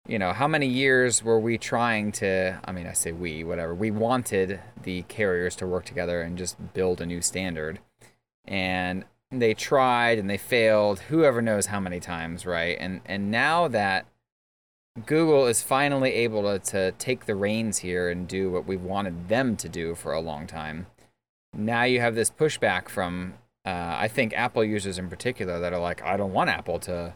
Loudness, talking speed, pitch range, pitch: -26 LUFS, 190 wpm, 90-115 Hz, 95 Hz